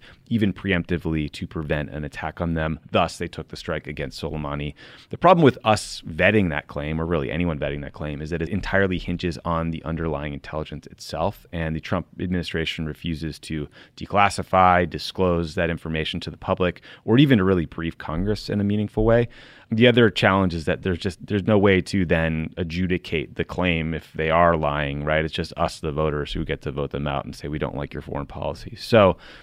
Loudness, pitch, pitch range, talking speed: -23 LUFS, 85 Hz, 80-95 Hz, 205 wpm